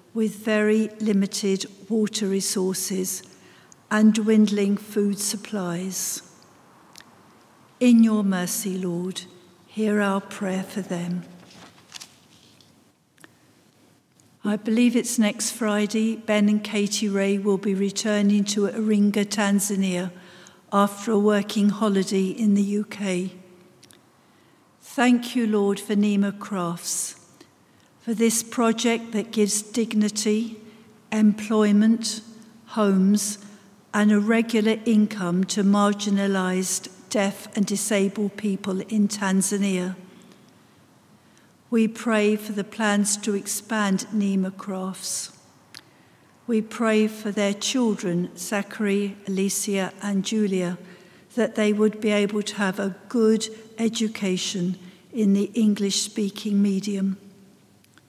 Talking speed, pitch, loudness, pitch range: 100 wpm, 205 Hz, -23 LUFS, 195-215 Hz